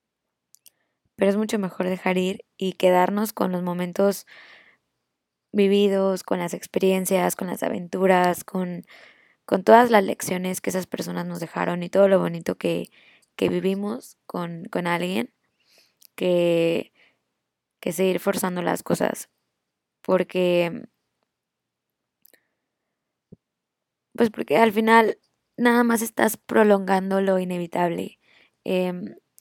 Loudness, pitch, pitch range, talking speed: -23 LUFS, 185 Hz, 180-205 Hz, 115 wpm